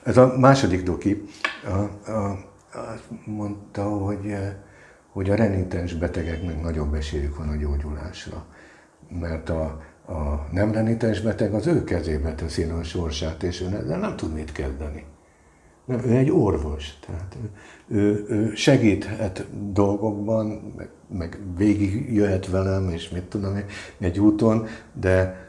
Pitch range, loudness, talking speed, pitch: 80-105 Hz, -24 LUFS, 130 wpm, 95 Hz